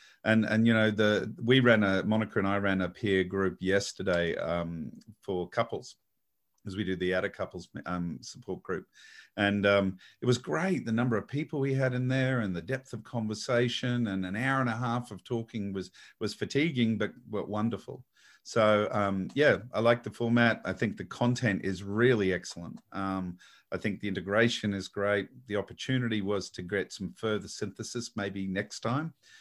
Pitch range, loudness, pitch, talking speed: 100-120 Hz, -30 LUFS, 105 Hz, 190 wpm